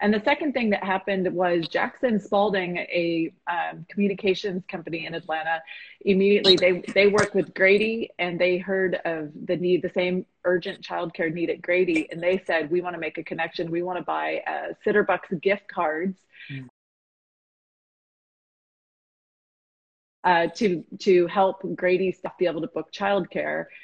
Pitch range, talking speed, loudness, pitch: 170-195 Hz, 155 wpm, -24 LUFS, 180 Hz